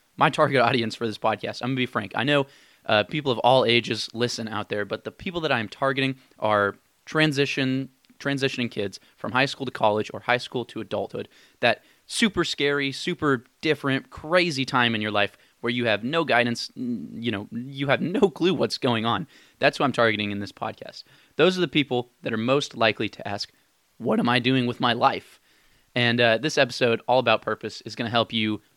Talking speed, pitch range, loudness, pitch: 205 wpm, 115-140 Hz, -24 LUFS, 125 Hz